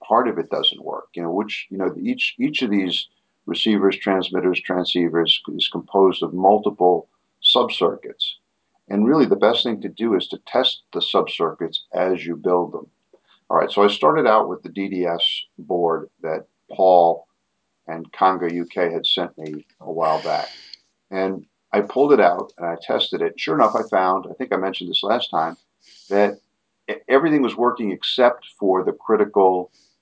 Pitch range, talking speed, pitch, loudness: 85-100 Hz, 175 wpm, 95 Hz, -20 LUFS